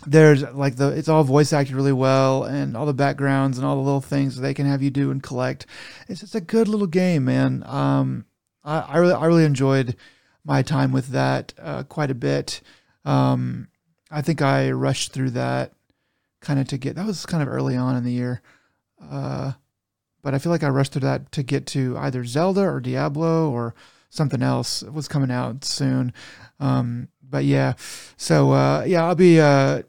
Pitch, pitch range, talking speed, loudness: 135 Hz, 125-150 Hz, 200 wpm, -21 LUFS